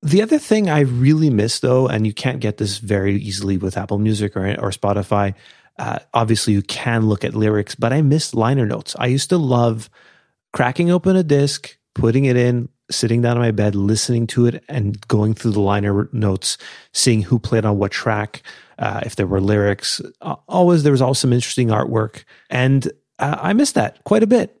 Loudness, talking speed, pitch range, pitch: -18 LUFS, 200 wpm, 105-130 Hz, 115 Hz